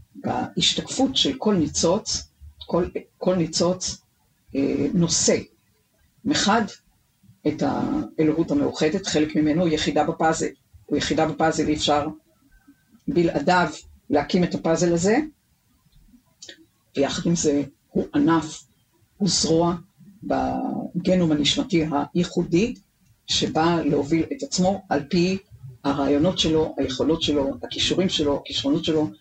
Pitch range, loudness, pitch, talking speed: 145-175 Hz, -22 LUFS, 160 Hz, 105 wpm